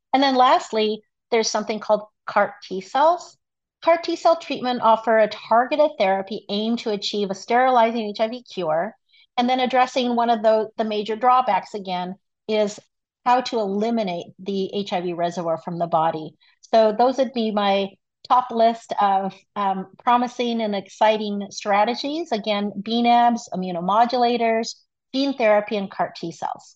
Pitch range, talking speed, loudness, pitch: 195-240 Hz, 150 wpm, -21 LUFS, 220 Hz